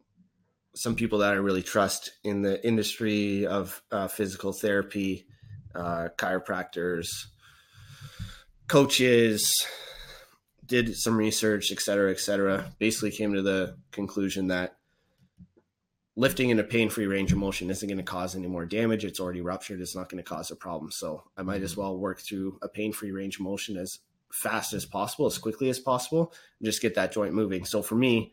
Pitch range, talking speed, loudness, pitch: 95-110 Hz, 180 wpm, -28 LUFS, 100 Hz